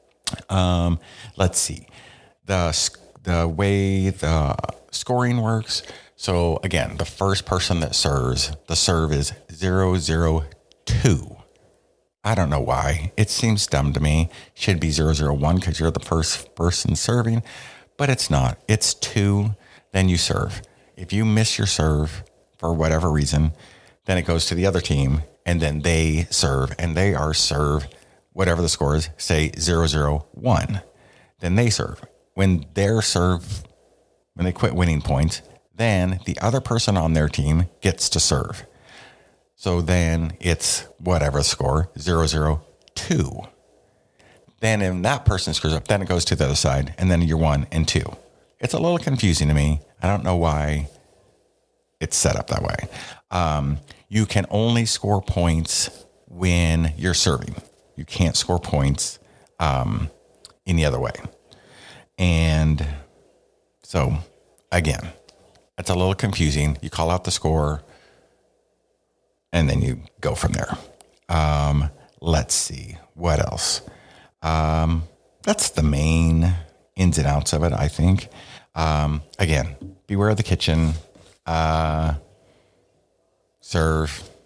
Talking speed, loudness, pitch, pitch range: 145 wpm, -22 LUFS, 85 Hz, 75-95 Hz